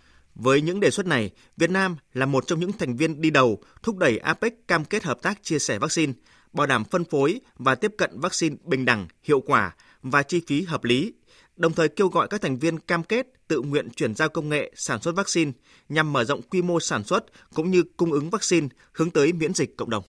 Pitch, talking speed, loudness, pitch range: 160 Hz, 230 wpm, -24 LUFS, 135-175 Hz